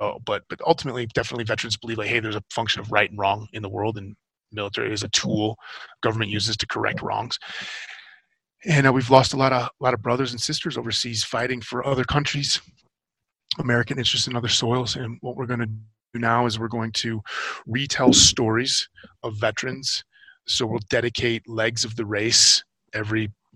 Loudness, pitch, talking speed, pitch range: -22 LUFS, 120 Hz, 190 wpm, 110-125 Hz